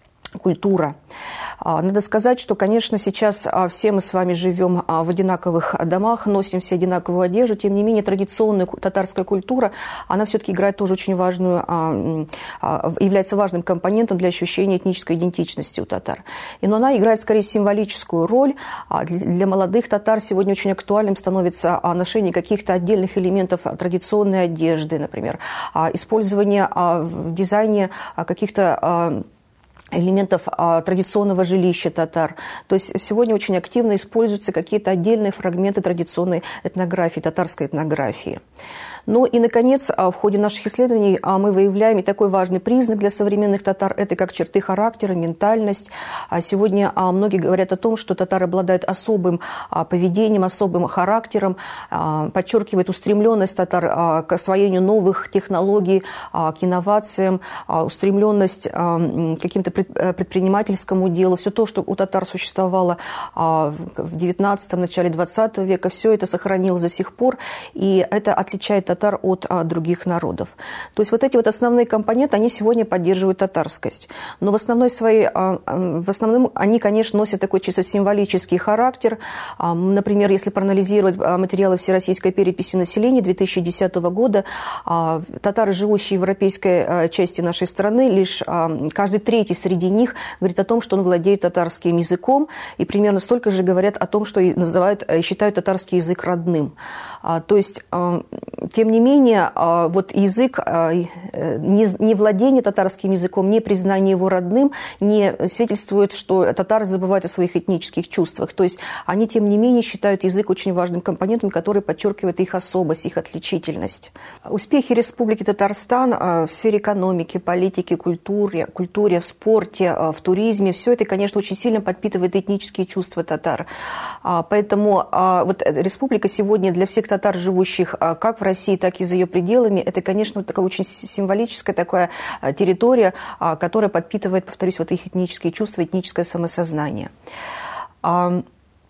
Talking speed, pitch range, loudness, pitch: 135 wpm, 180-210 Hz, -19 LUFS, 190 Hz